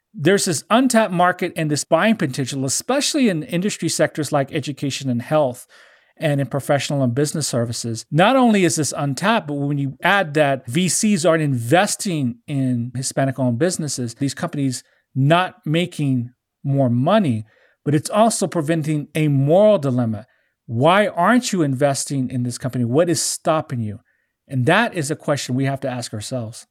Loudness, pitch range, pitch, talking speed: -19 LUFS, 130-170 Hz, 145 Hz, 165 wpm